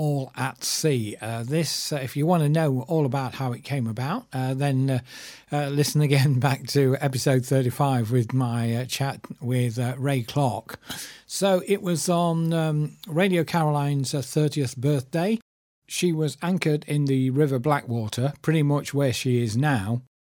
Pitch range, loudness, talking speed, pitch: 130-155 Hz, -24 LUFS, 170 wpm, 140 Hz